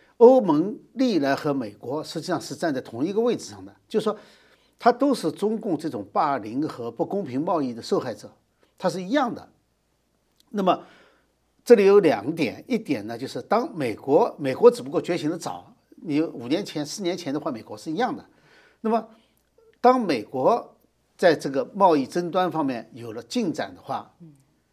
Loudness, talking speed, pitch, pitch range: -24 LUFS, 255 characters per minute, 215 Hz, 170-255 Hz